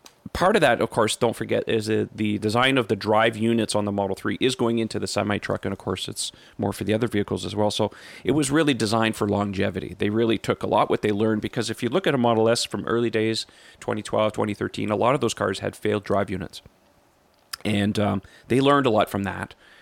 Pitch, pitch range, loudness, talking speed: 110 Hz, 100-115 Hz, -23 LUFS, 245 wpm